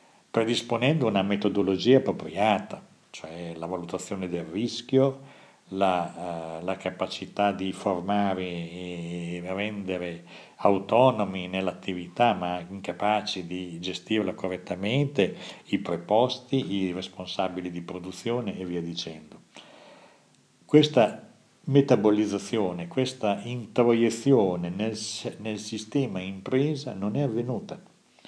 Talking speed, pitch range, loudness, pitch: 95 wpm, 90-115 Hz, -27 LUFS, 100 Hz